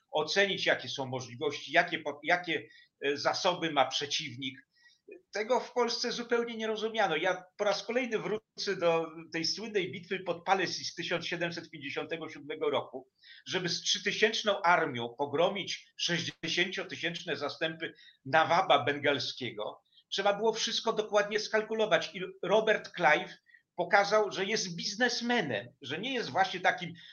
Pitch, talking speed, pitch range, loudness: 180 Hz, 125 wpm, 160-210 Hz, -31 LUFS